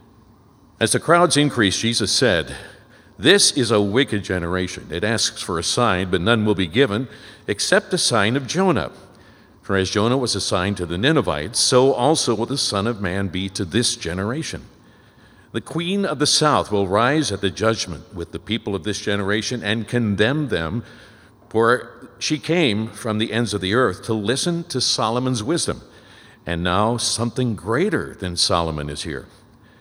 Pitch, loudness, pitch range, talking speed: 110 Hz, -20 LUFS, 100-125 Hz, 175 wpm